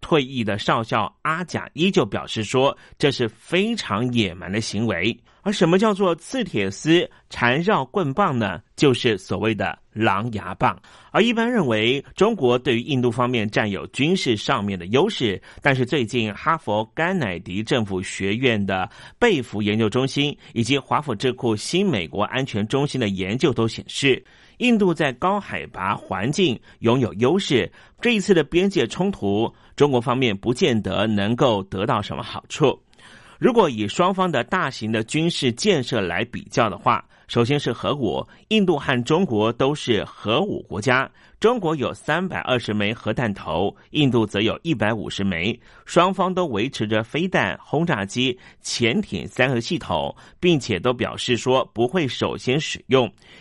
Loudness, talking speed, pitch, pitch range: -22 LUFS, 250 characters per minute, 125 Hz, 110-160 Hz